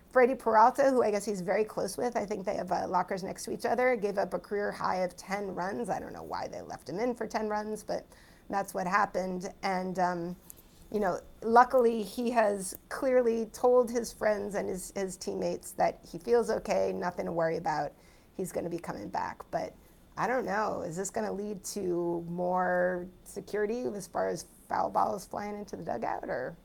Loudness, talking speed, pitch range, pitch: -31 LUFS, 210 wpm, 185-225 Hz, 205 Hz